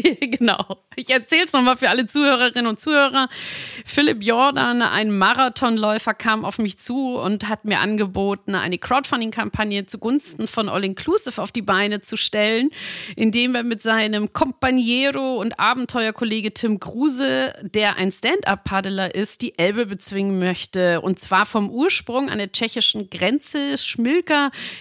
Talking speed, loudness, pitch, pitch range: 145 wpm, -20 LUFS, 225 Hz, 200-260 Hz